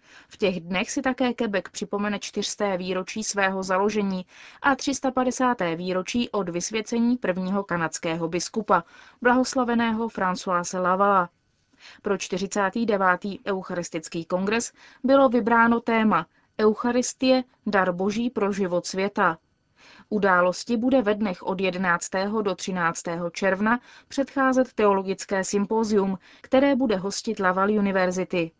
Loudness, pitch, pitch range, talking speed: -24 LUFS, 200 Hz, 185-235 Hz, 110 wpm